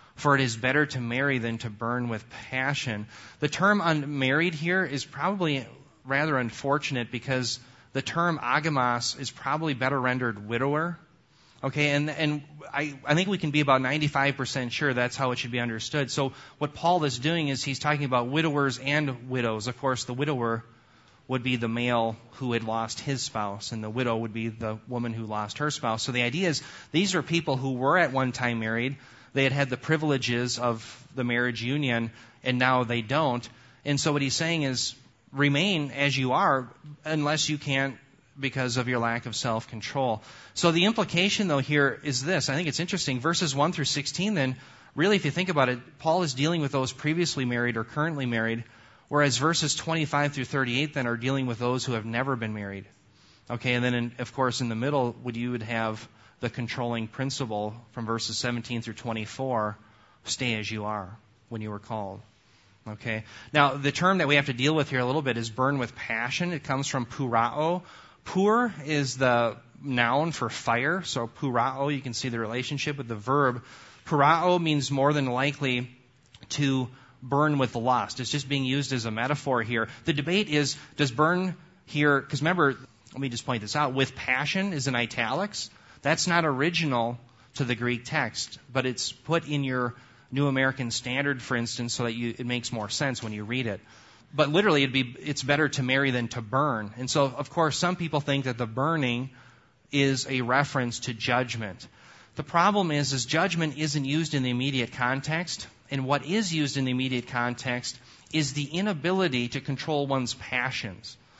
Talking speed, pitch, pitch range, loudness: 190 wpm, 130 Hz, 120-145 Hz, -27 LUFS